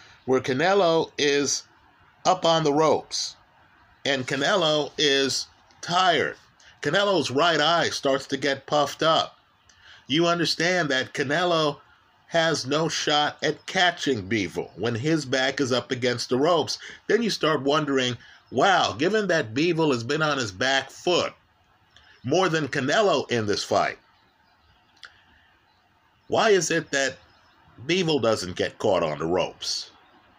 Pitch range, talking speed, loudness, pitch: 130-160 Hz, 135 wpm, -23 LUFS, 145 Hz